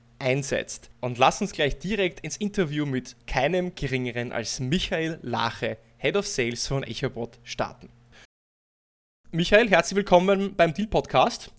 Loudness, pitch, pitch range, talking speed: -25 LUFS, 135 Hz, 120-180 Hz, 135 wpm